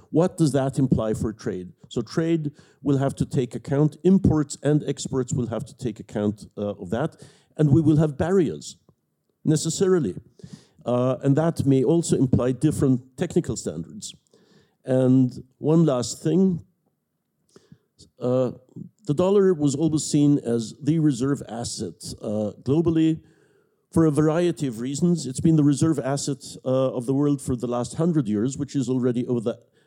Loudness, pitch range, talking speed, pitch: -23 LUFS, 130-160 Hz, 160 wpm, 145 Hz